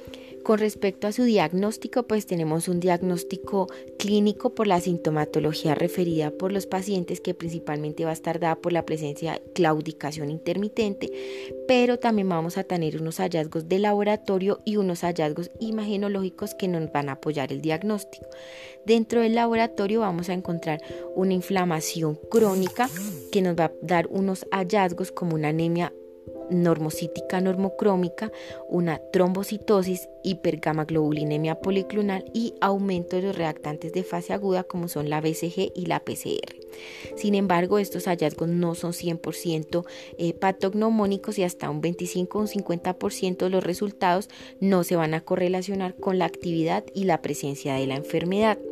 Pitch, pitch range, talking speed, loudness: 180 Hz, 160-200 Hz, 150 wpm, -26 LUFS